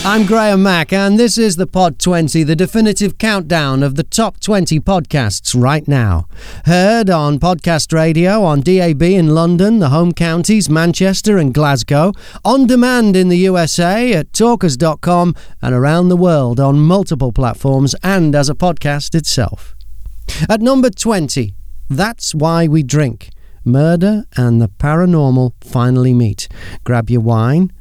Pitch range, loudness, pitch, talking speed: 135-190 Hz, -12 LUFS, 165 Hz, 145 wpm